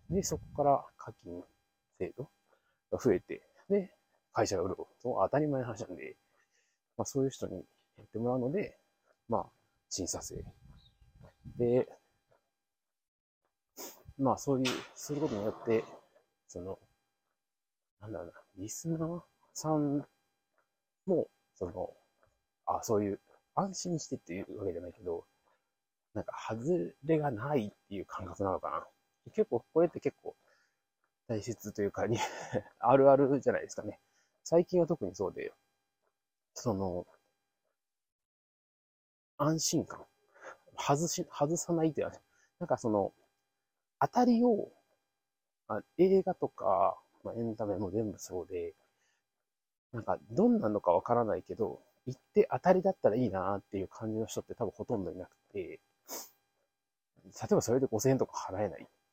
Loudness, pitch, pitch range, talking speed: -33 LUFS, 140 Hz, 115-175 Hz, 265 characters per minute